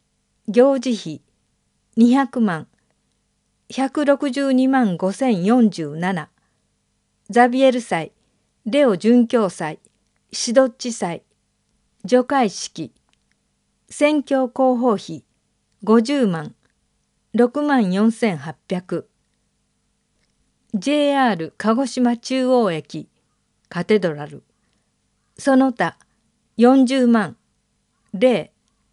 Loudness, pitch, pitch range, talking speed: -19 LUFS, 235 Hz, 185-260 Hz, 100 characters per minute